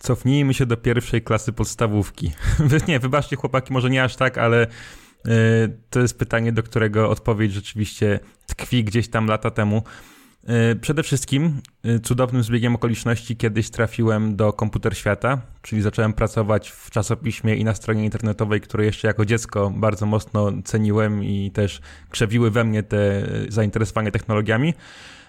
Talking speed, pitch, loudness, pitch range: 155 wpm, 115 Hz, -21 LUFS, 105-120 Hz